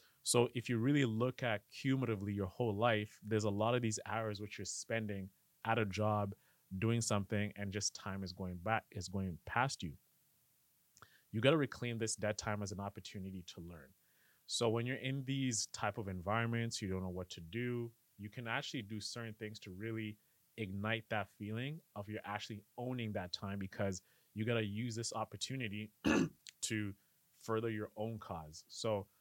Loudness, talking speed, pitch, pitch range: -39 LUFS, 185 wpm, 110 Hz, 100-115 Hz